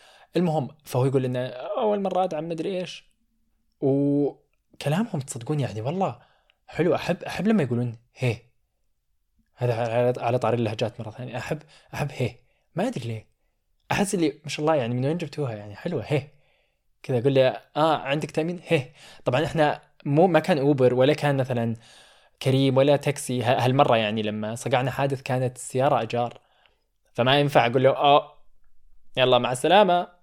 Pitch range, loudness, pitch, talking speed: 120-155 Hz, -24 LUFS, 135 Hz, 155 wpm